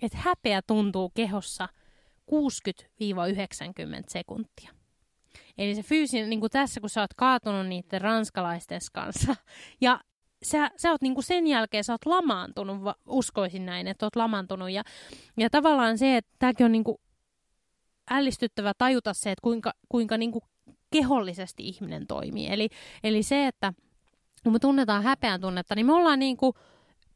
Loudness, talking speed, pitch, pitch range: -27 LUFS, 150 wpm, 225 Hz, 200-260 Hz